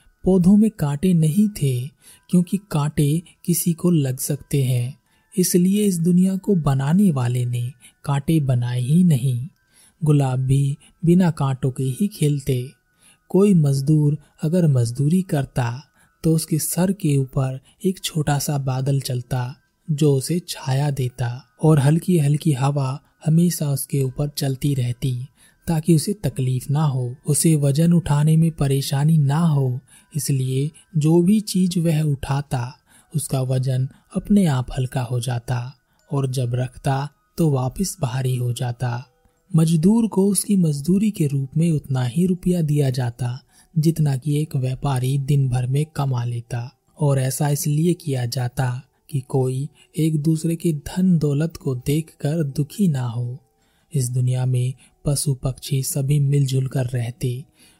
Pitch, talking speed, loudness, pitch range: 145 Hz, 145 wpm, -21 LUFS, 130-165 Hz